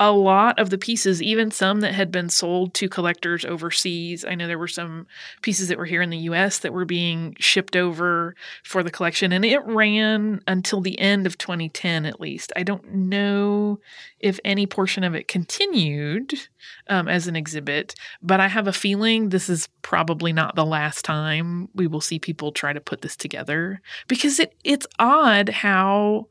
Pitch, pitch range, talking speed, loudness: 185 Hz, 170-205 Hz, 190 wpm, -21 LUFS